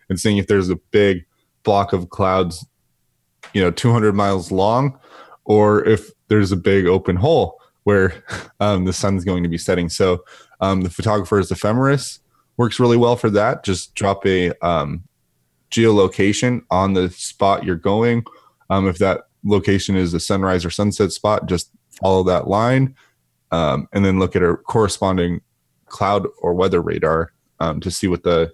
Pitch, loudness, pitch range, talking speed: 95 Hz, -18 LUFS, 90-105 Hz, 165 wpm